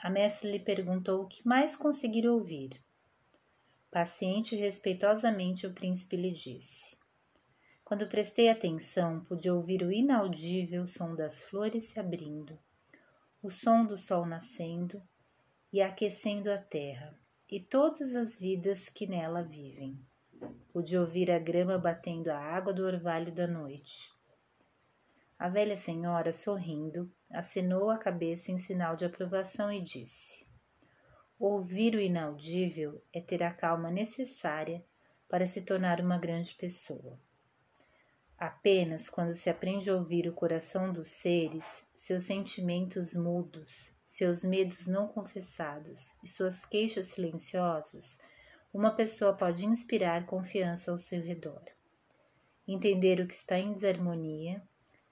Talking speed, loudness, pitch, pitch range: 125 wpm, -33 LUFS, 185 Hz, 170-200 Hz